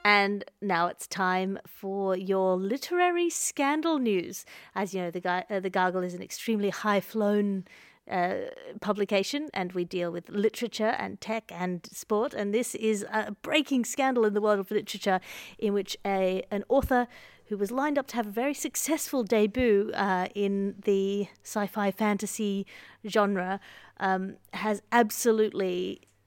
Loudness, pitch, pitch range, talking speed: -29 LUFS, 205 Hz, 190-230 Hz, 150 wpm